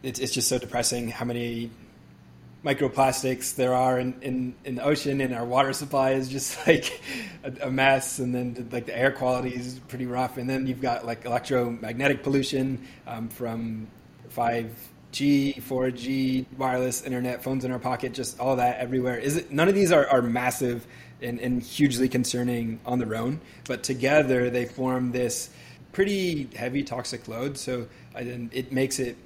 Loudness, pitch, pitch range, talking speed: -26 LUFS, 125 Hz, 120-135 Hz, 170 wpm